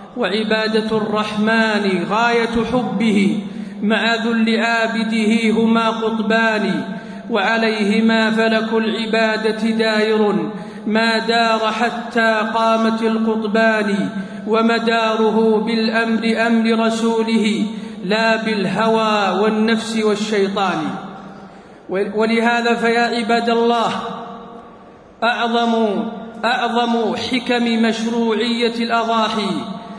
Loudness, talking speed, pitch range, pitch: -17 LUFS, 70 wpm, 215-230 Hz, 225 Hz